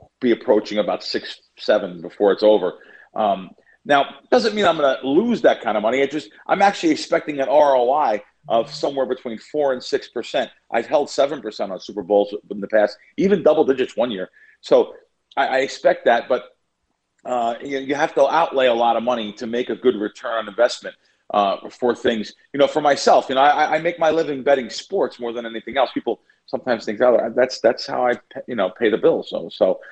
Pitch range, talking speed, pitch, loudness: 115-165 Hz, 215 wpm, 135 Hz, -20 LUFS